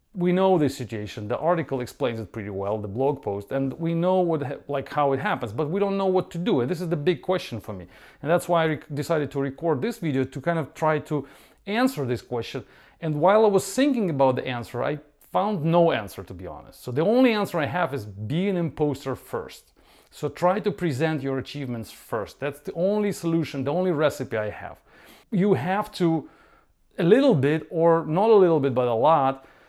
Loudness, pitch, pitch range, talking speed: -24 LUFS, 150 Hz, 130-175 Hz, 225 wpm